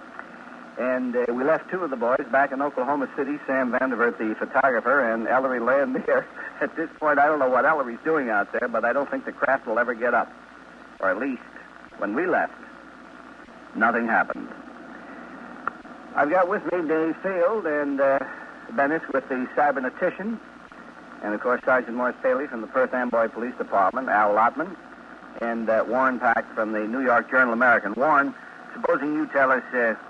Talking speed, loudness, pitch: 180 wpm, -23 LUFS, 140 Hz